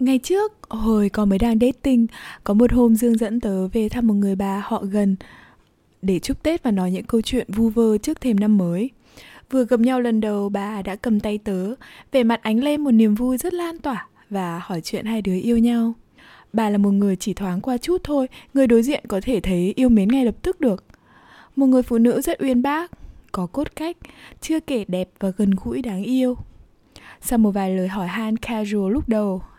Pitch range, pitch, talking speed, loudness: 200-255 Hz, 225 Hz, 220 wpm, -21 LUFS